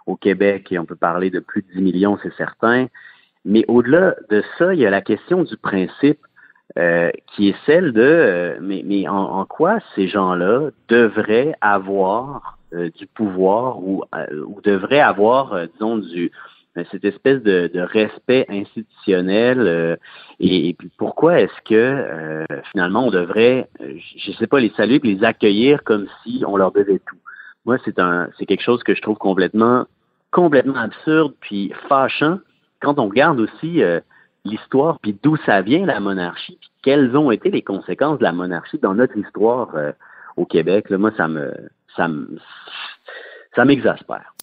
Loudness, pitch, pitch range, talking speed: -17 LUFS, 100 Hz, 95-120 Hz, 180 wpm